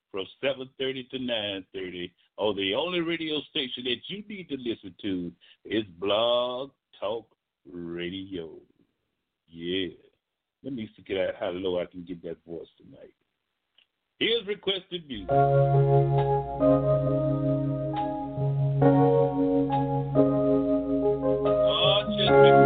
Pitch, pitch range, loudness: 95 Hz, 80-140 Hz, -26 LUFS